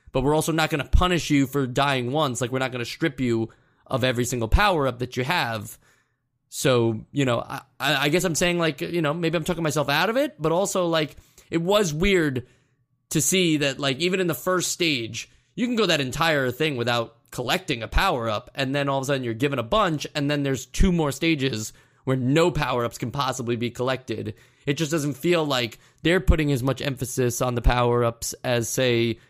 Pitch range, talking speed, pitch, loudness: 125-160 Hz, 215 wpm, 140 Hz, -24 LUFS